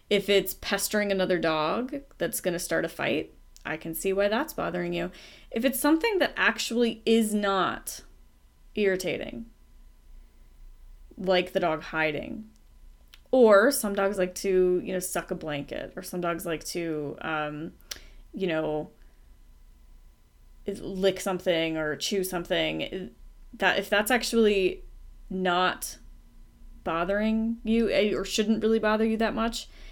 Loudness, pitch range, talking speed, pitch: -27 LUFS, 160-220 Hz, 130 wpm, 185 Hz